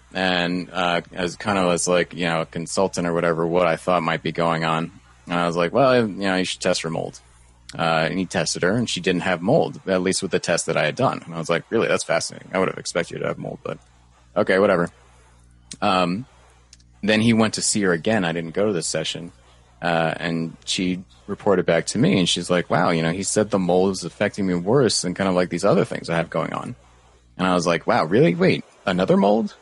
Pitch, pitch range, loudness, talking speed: 85 Hz, 80-95 Hz, -21 LUFS, 250 wpm